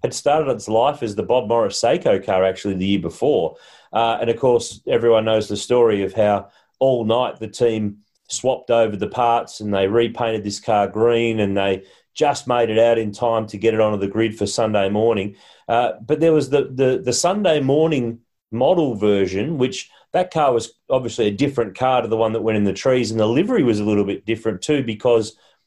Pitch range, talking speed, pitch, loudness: 105-125 Hz, 215 wpm, 115 Hz, -19 LUFS